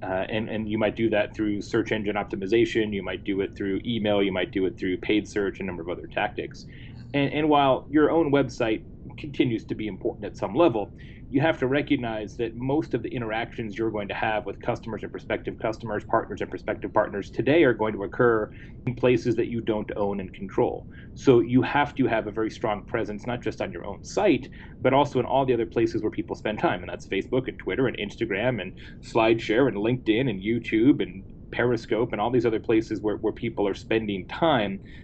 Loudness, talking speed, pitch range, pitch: -26 LUFS, 225 wpm, 105-125 Hz, 115 Hz